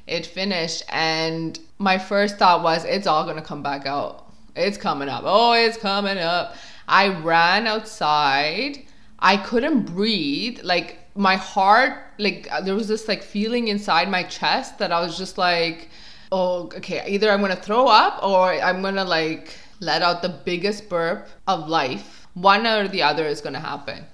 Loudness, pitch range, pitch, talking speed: -21 LUFS, 165-205 Hz, 185 Hz, 170 wpm